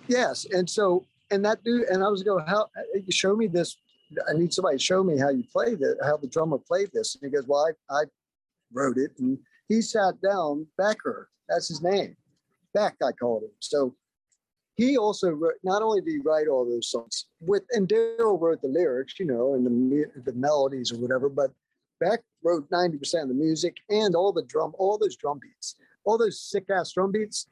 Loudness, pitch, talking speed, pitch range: -26 LUFS, 180 Hz, 210 wpm, 150-215 Hz